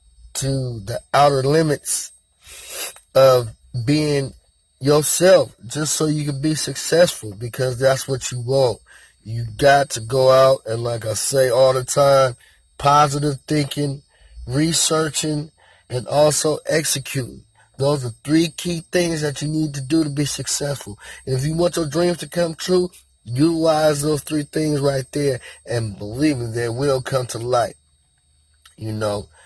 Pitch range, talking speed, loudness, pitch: 120-150 Hz, 150 wpm, -19 LUFS, 135 Hz